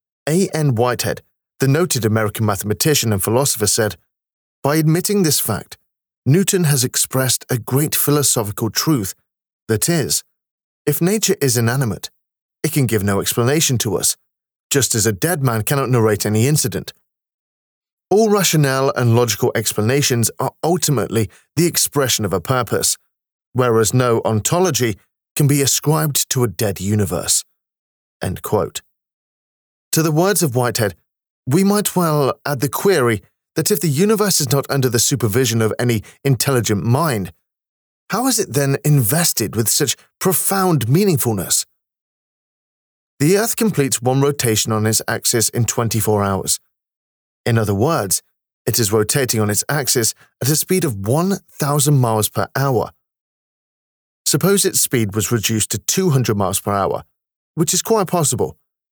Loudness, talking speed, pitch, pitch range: -17 LUFS, 145 wpm, 125 Hz, 110-155 Hz